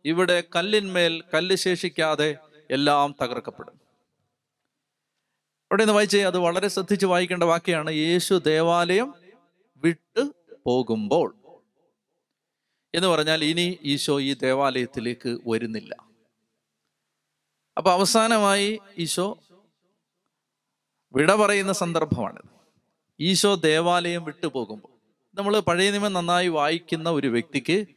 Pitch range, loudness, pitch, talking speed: 150-195 Hz, -23 LUFS, 175 Hz, 90 wpm